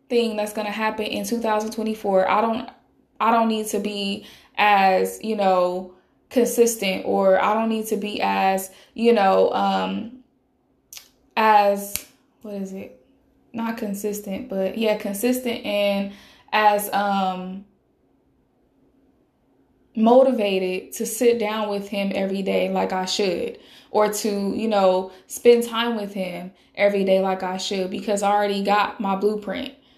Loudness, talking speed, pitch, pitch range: -22 LUFS, 140 wpm, 205 Hz, 190-225 Hz